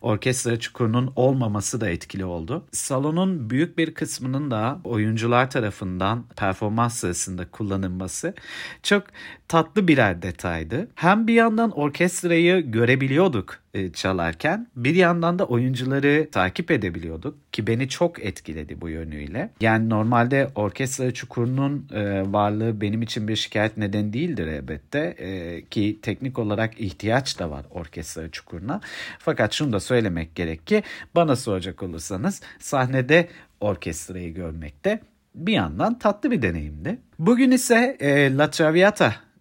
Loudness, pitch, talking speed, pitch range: -23 LUFS, 115 Hz, 130 wpm, 95-150 Hz